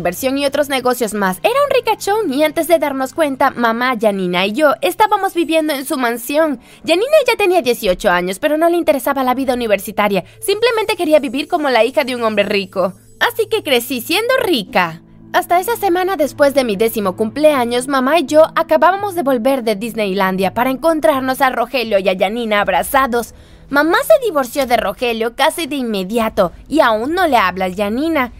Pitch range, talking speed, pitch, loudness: 225-320 Hz, 185 wpm, 270 Hz, -15 LUFS